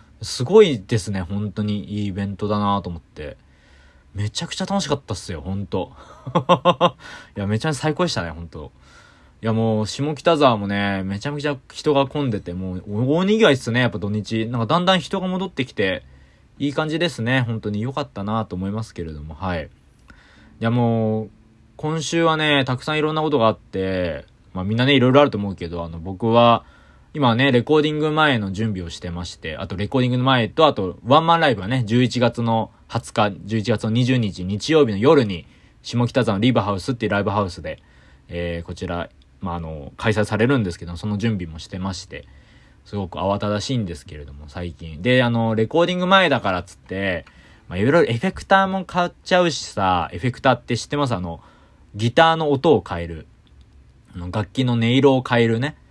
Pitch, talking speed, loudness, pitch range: 110 Hz, 395 characters per minute, -20 LUFS, 95-135 Hz